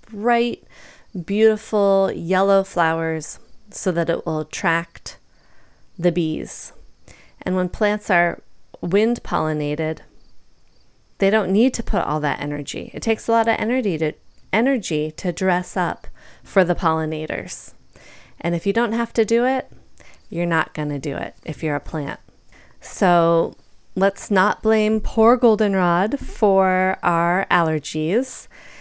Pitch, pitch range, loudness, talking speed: 185 Hz, 165-215 Hz, -20 LUFS, 135 wpm